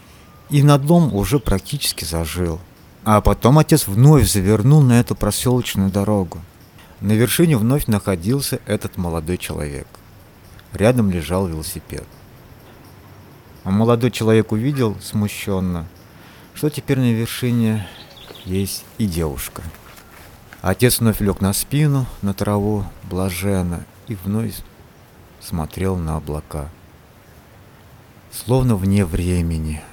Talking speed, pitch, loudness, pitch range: 105 wpm, 100 Hz, -18 LUFS, 90-120 Hz